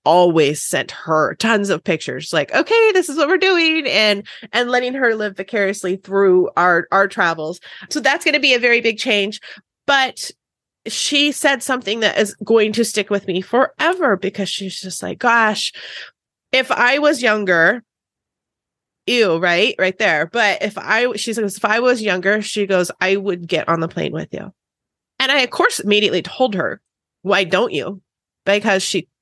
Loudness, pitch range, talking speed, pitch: -16 LUFS, 190-250 Hz, 180 wpm, 210 Hz